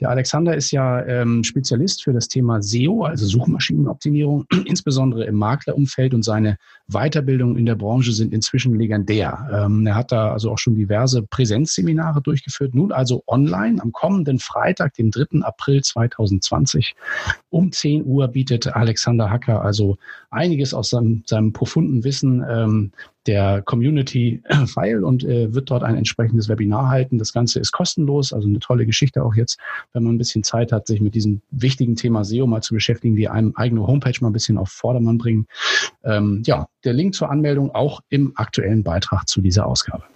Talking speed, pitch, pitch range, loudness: 175 wpm, 120 Hz, 110-140 Hz, -19 LUFS